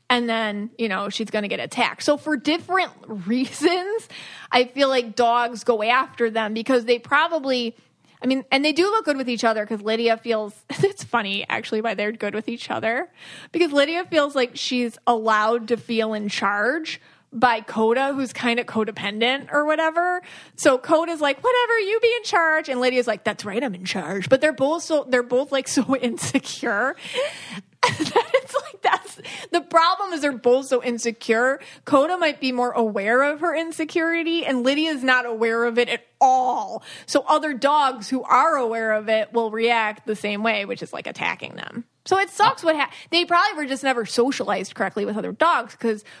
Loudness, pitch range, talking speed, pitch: -22 LUFS, 230-315 Hz, 195 wpm, 255 Hz